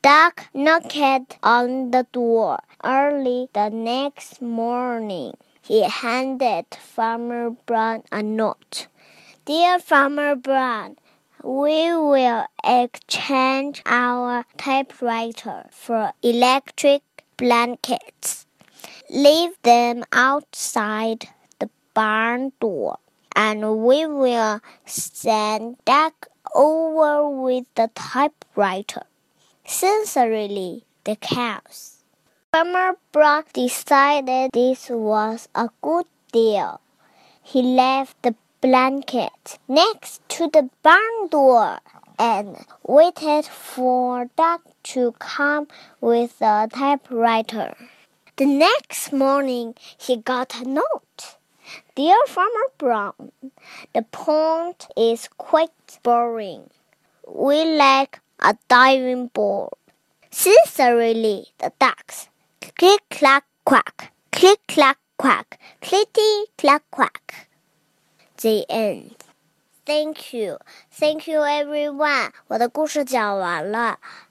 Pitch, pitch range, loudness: 260 Hz, 235-300 Hz, -19 LUFS